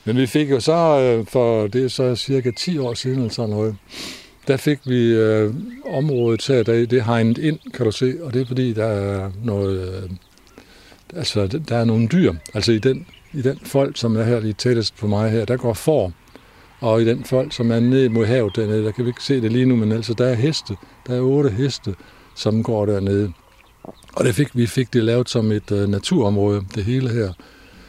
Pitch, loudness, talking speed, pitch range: 120 Hz, -19 LUFS, 215 wpm, 110-130 Hz